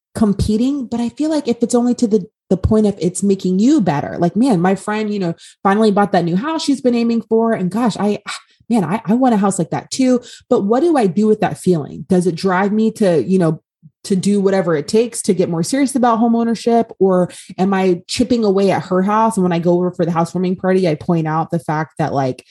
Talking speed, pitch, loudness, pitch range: 250 wpm, 200 Hz, -16 LUFS, 180-230 Hz